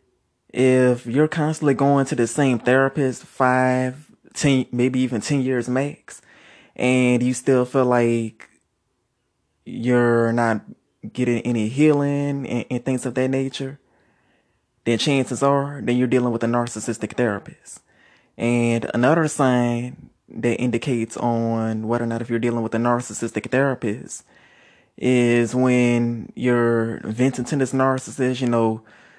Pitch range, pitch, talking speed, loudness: 115-130 Hz, 125 Hz, 135 wpm, -21 LUFS